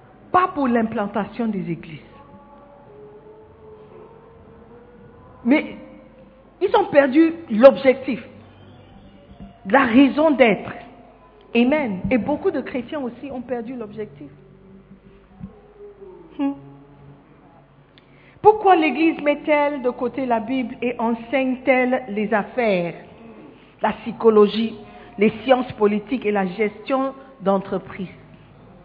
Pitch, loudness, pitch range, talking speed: 230 Hz, -20 LUFS, 190-270 Hz, 90 wpm